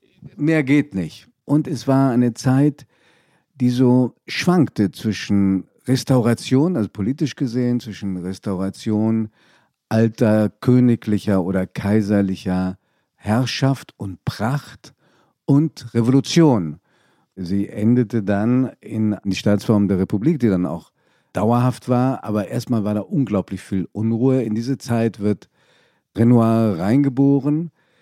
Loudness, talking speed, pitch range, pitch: -19 LUFS, 115 wpm, 105-130 Hz, 115 Hz